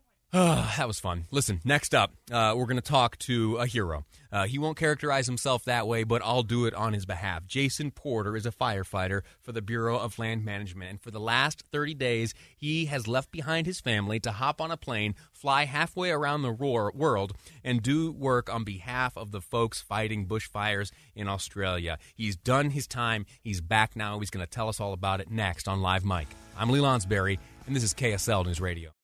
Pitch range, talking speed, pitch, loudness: 100-130 Hz, 215 wpm, 115 Hz, -29 LUFS